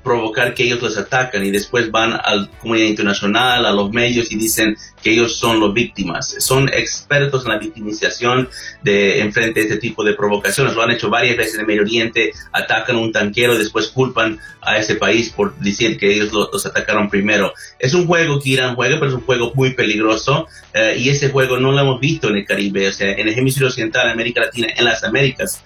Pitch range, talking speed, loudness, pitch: 105-130 Hz, 225 wpm, -16 LUFS, 115 Hz